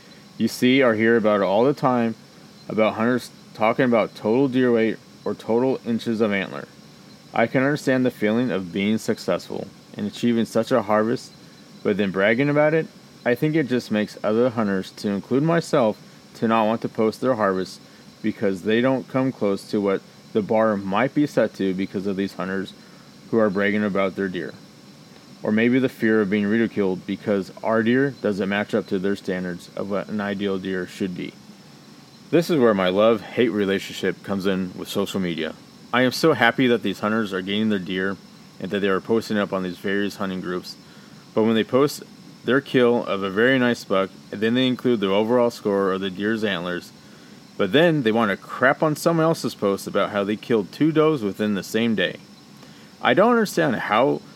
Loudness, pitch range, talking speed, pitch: -22 LUFS, 100-125 Hz, 200 wpm, 110 Hz